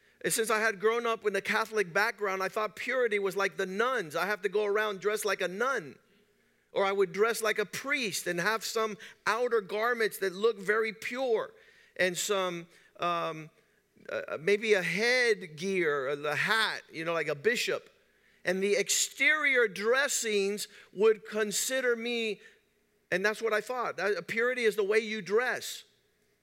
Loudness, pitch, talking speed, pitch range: -30 LUFS, 215 Hz, 170 wpm, 195-230 Hz